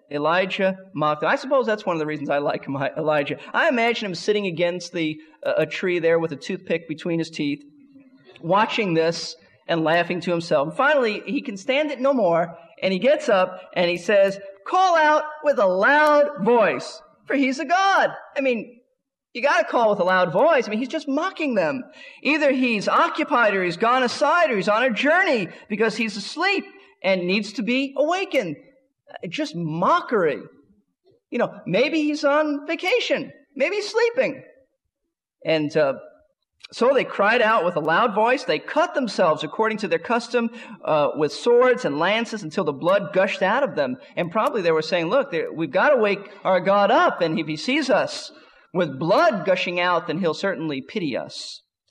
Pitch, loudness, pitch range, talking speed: 235 Hz, -21 LUFS, 180-290 Hz, 190 wpm